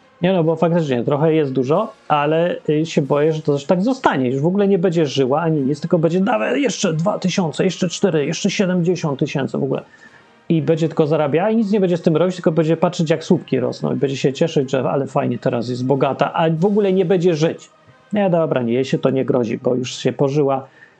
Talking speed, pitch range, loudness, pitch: 235 wpm, 140-180 Hz, -18 LUFS, 160 Hz